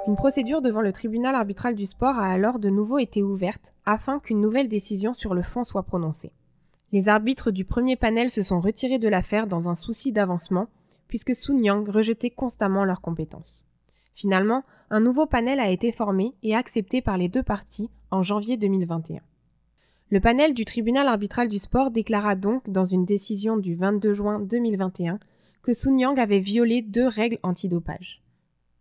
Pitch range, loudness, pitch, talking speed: 190-240 Hz, -24 LUFS, 210 Hz, 175 wpm